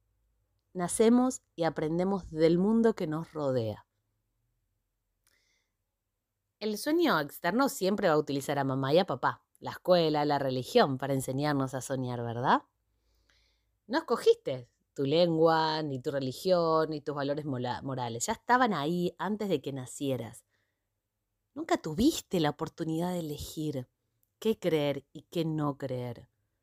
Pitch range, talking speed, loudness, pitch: 115-170 Hz, 135 wpm, -30 LUFS, 140 Hz